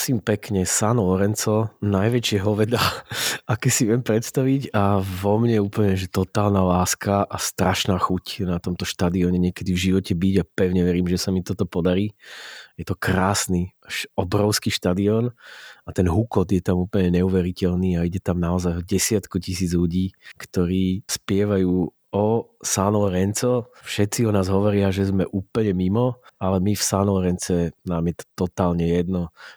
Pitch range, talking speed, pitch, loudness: 90-105 Hz, 155 wpm, 95 Hz, -22 LUFS